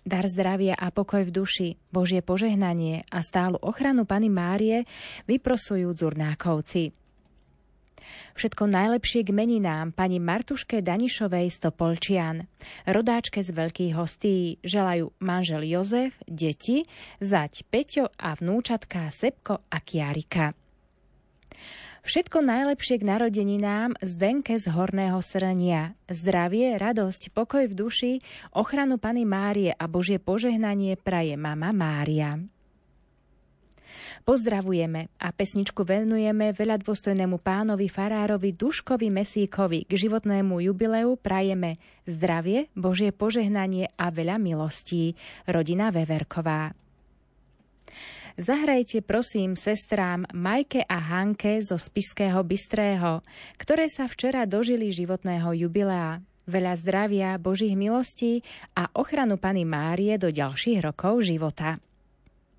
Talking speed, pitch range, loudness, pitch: 105 wpm, 175-220 Hz, -26 LUFS, 195 Hz